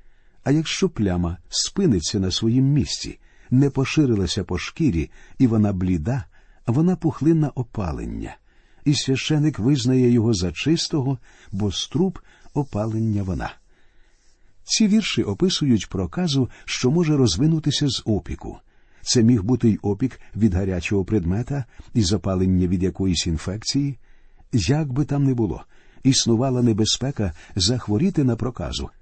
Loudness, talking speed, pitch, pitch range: -22 LUFS, 120 wpm, 115 Hz, 95-140 Hz